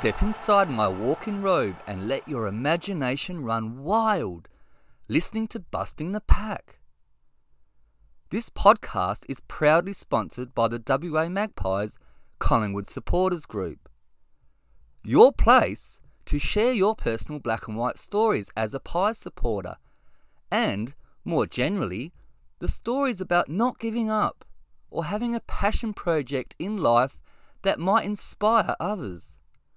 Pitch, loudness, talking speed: 155 Hz, -25 LUFS, 125 wpm